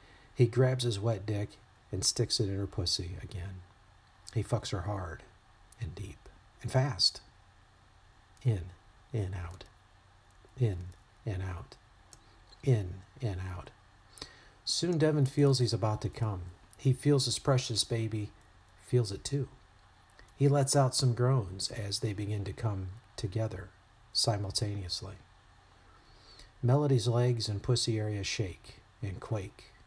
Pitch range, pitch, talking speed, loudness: 100-120 Hz, 105 Hz, 130 wpm, -32 LUFS